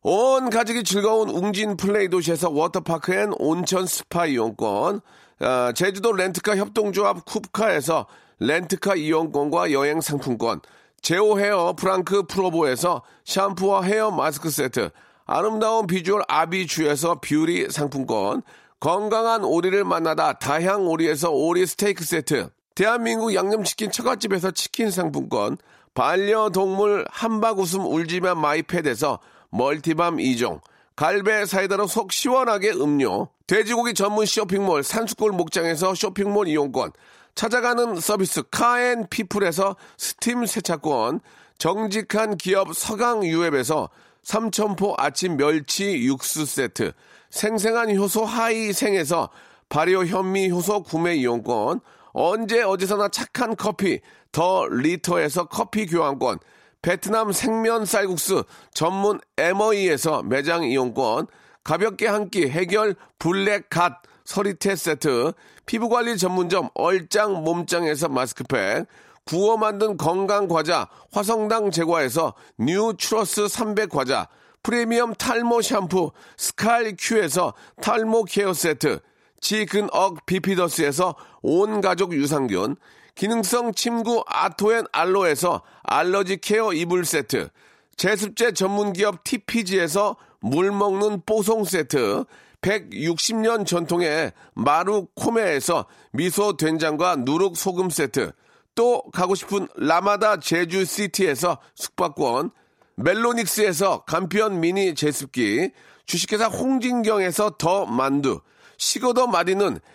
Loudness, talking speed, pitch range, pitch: -22 LUFS, 265 characters per minute, 175-220 Hz, 200 Hz